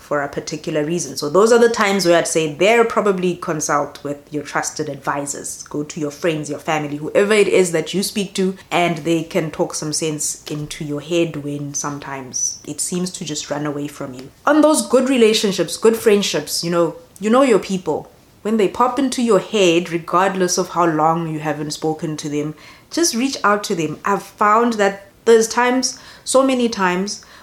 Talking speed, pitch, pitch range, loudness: 200 wpm, 170 Hz, 150-205 Hz, -18 LUFS